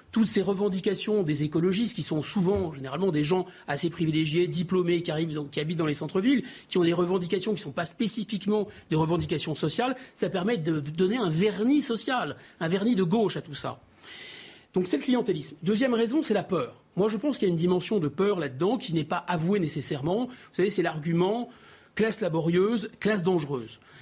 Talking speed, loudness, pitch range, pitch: 200 wpm, -27 LUFS, 165-210 Hz, 185 Hz